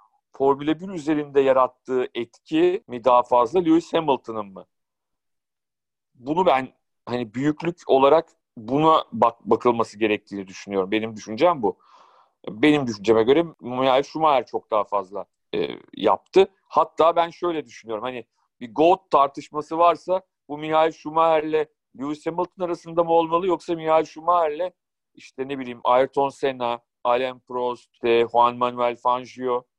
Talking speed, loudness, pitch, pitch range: 125 wpm, -22 LUFS, 140 Hz, 120-165 Hz